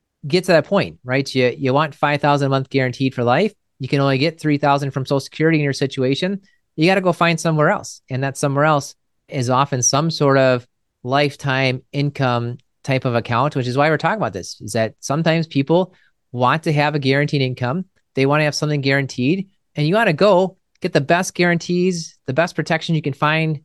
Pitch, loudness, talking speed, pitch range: 145 Hz, -18 LUFS, 220 wpm, 135-165 Hz